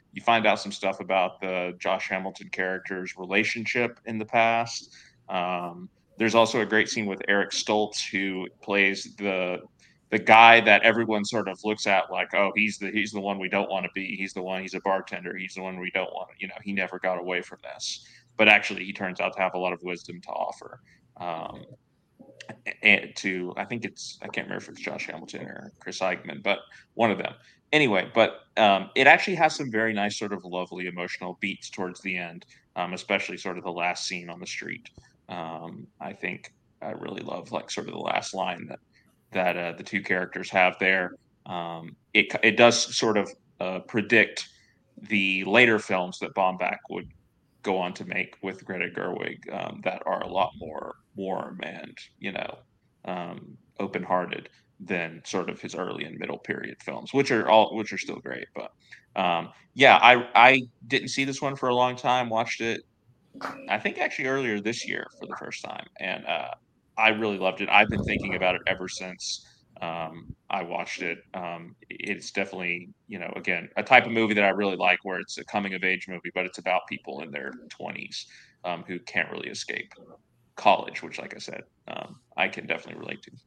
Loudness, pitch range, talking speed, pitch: -25 LUFS, 90-110 Hz, 200 wpm, 95 Hz